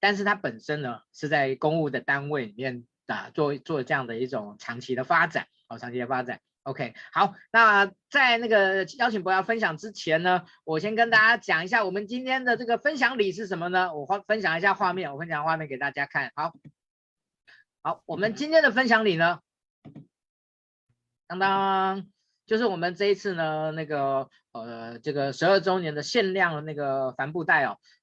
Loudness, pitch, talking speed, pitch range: -25 LUFS, 175 Hz, 275 characters per minute, 140-205 Hz